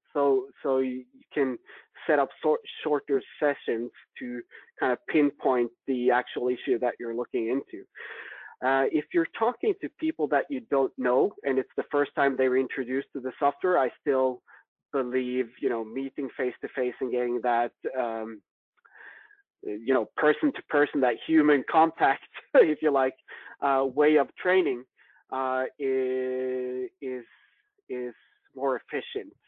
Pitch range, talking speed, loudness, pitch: 125-145 Hz, 155 wpm, -27 LUFS, 135 Hz